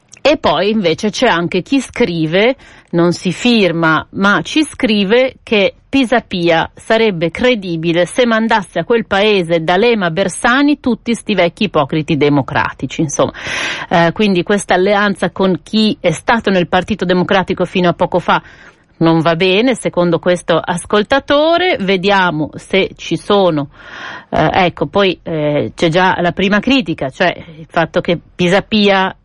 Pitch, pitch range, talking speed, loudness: 185 Hz, 170-215 Hz, 145 wpm, -13 LUFS